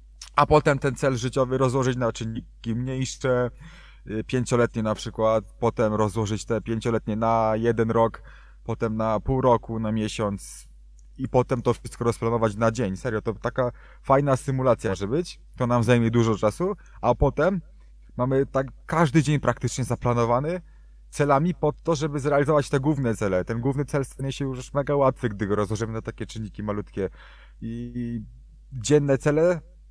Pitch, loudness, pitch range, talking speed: 120 Hz, -25 LUFS, 110-135 Hz, 155 wpm